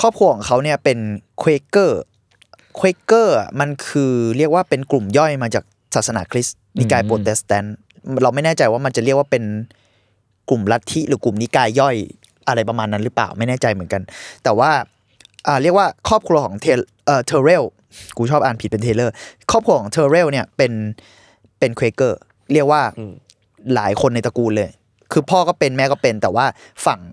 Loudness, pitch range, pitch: -17 LUFS, 110-145 Hz, 120 Hz